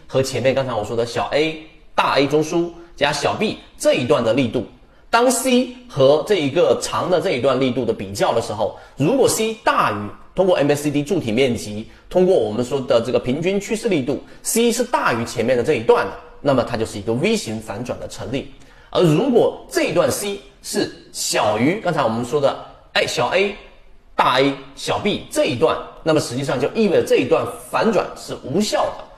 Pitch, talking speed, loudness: 155 Hz, 290 characters per minute, -19 LUFS